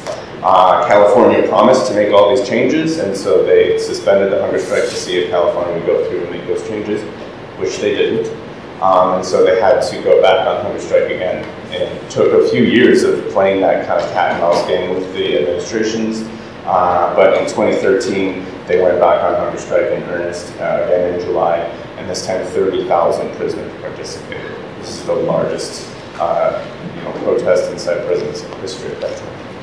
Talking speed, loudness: 195 wpm, -14 LUFS